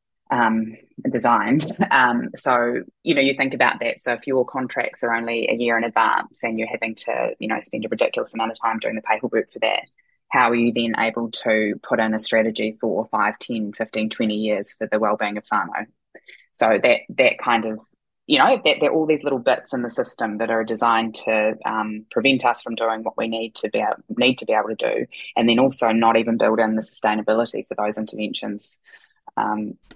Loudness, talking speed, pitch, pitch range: -21 LUFS, 215 wpm, 115 Hz, 110-120 Hz